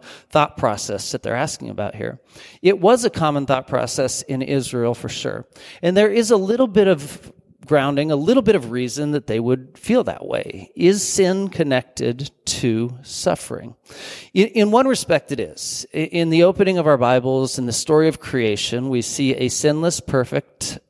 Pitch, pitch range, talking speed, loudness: 150 Hz, 125-190 Hz, 180 wpm, -19 LUFS